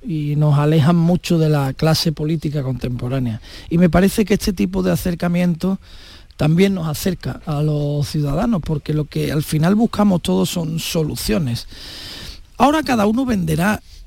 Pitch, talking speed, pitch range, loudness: 160 Hz, 155 wpm, 145-185 Hz, -18 LUFS